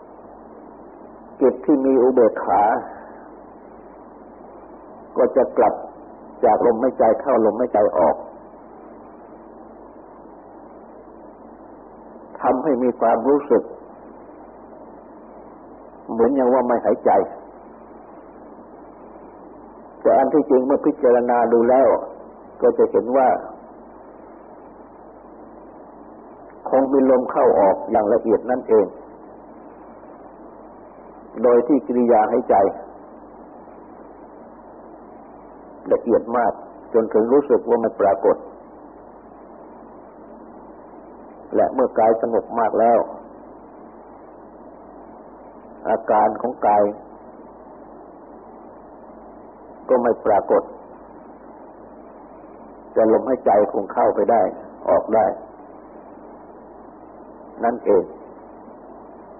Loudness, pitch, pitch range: -18 LUFS, 125 Hz, 115-135 Hz